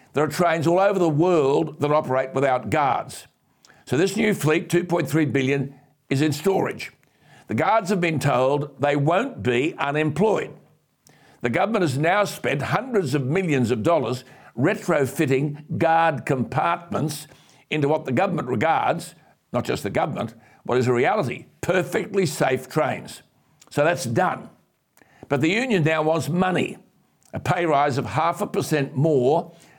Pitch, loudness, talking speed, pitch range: 155 Hz, -22 LUFS, 150 wpm, 140-175 Hz